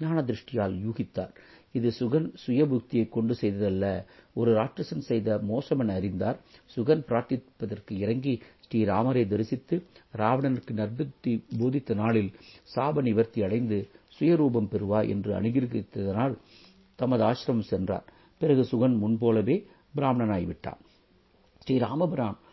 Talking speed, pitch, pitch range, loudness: 85 wpm, 115 Hz, 105-130 Hz, -28 LUFS